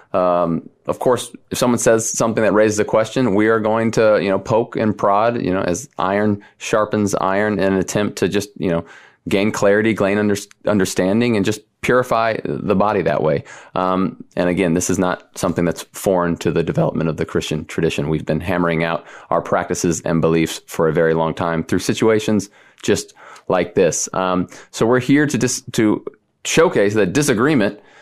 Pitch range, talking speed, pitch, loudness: 85-110 Hz, 195 wpm, 100 Hz, -18 LUFS